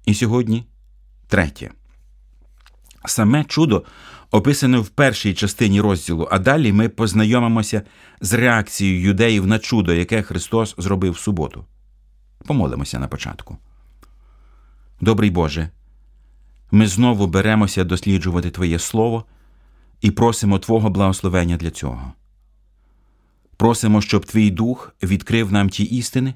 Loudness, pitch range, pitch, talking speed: -18 LUFS, 85-115 Hz, 100 Hz, 110 wpm